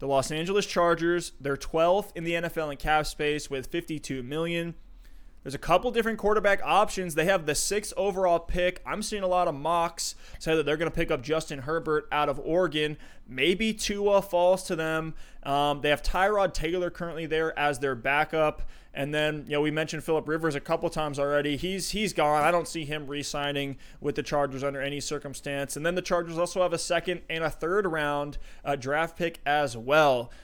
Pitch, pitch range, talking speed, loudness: 160 Hz, 145-175 Hz, 205 wpm, -27 LUFS